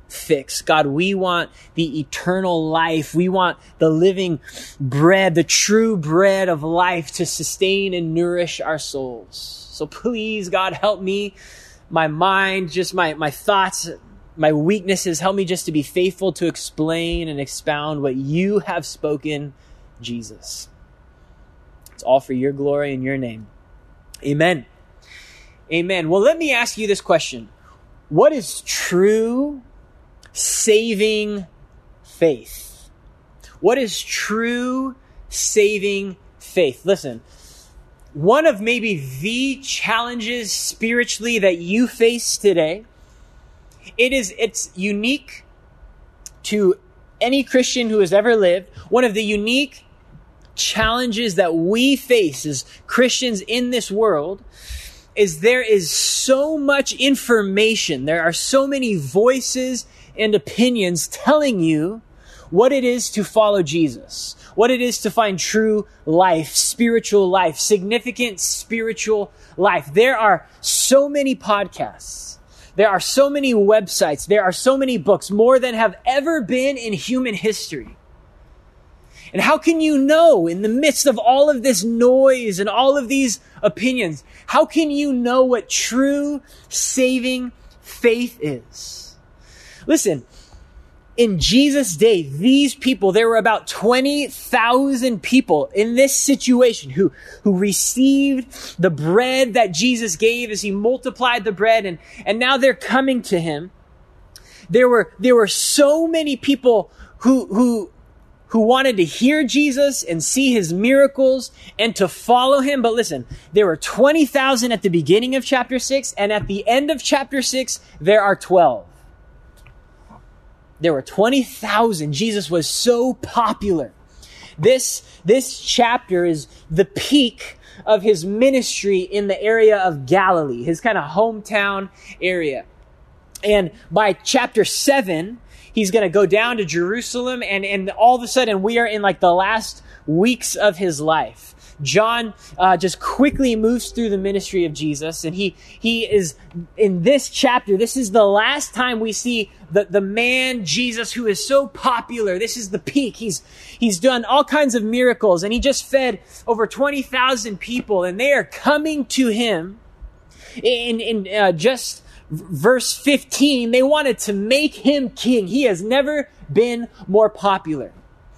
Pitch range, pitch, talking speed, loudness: 180-250 Hz, 215 Hz, 145 wpm, -18 LUFS